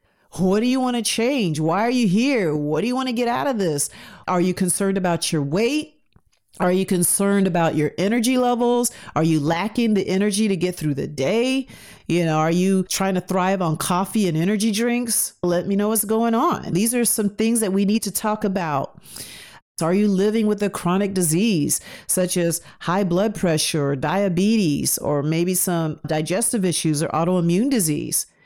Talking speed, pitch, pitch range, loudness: 195 wpm, 190 Hz, 165-220 Hz, -20 LUFS